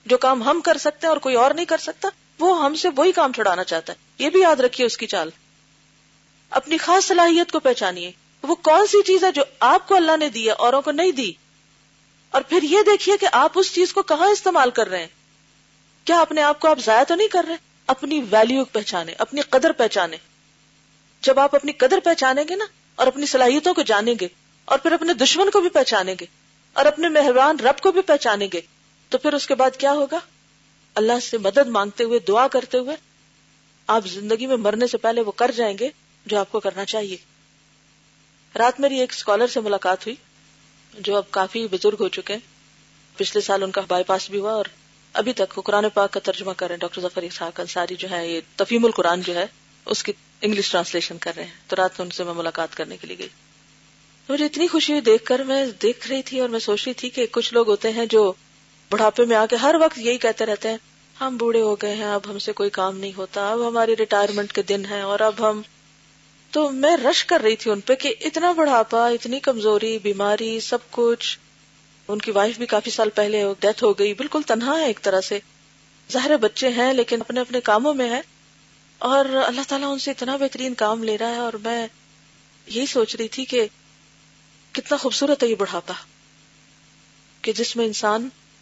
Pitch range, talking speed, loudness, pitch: 185-275 Hz, 210 wpm, -20 LUFS, 225 Hz